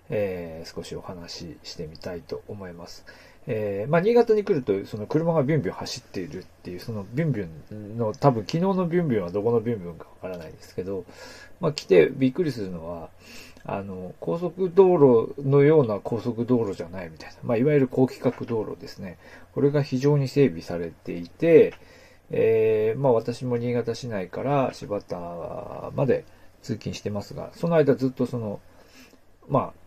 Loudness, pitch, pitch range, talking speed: -24 LUFS, 120 Hz, 100-155 Hz, 360 characters per minute